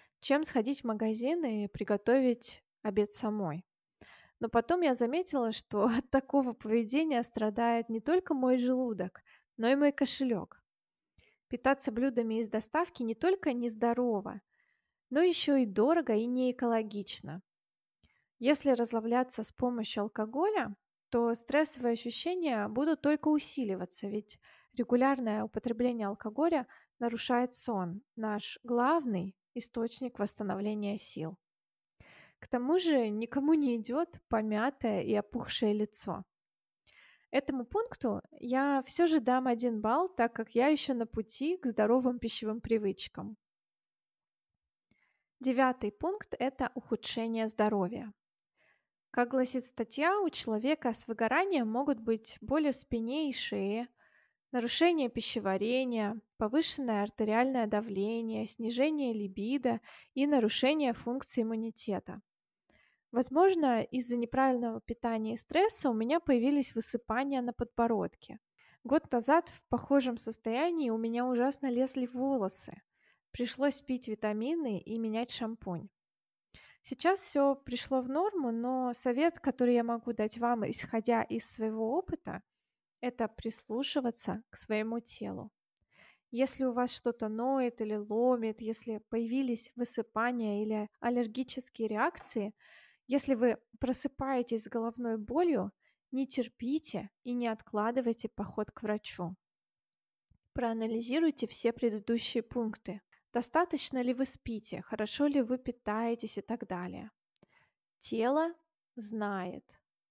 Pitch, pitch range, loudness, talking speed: 240 Hz, 220-270 Hz, -33 LUFS, 115 wpm